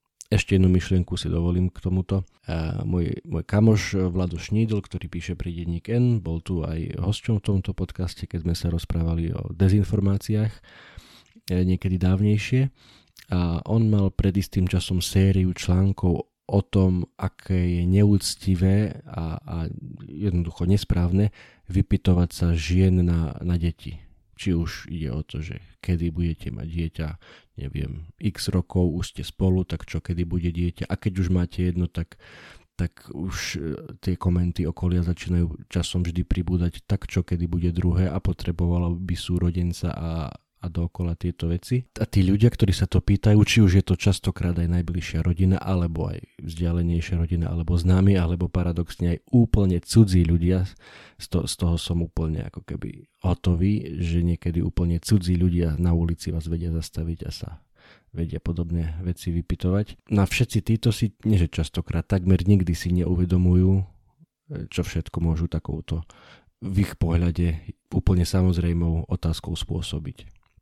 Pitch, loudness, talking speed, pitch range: 90 Hz, -24 LUFS, 150 wpm, 85-95 Hz